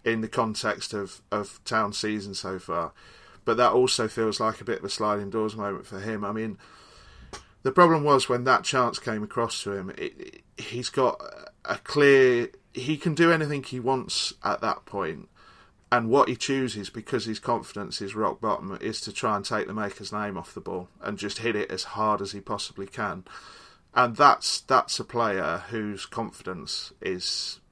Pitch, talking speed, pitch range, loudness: 110 Hz, 195 wpm, 100-130 Hz, -26 LUFS